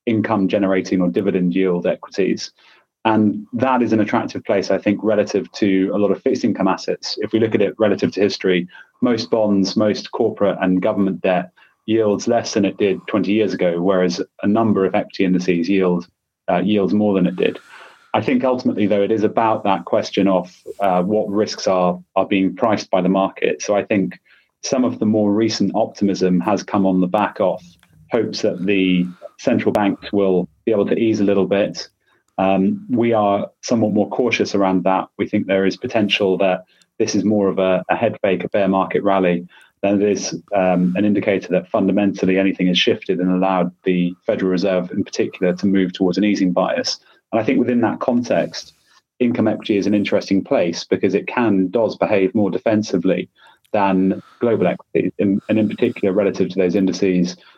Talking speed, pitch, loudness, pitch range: 190 wpm, 95 Hz, -18 LUFS, 95-105 Hz